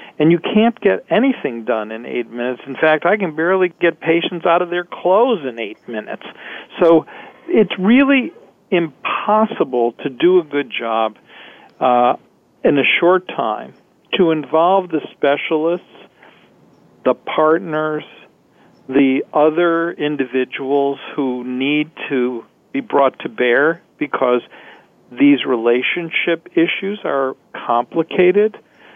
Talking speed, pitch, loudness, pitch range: 120 wpm, 160 Hz, -17 LUFS, 135-180 Hz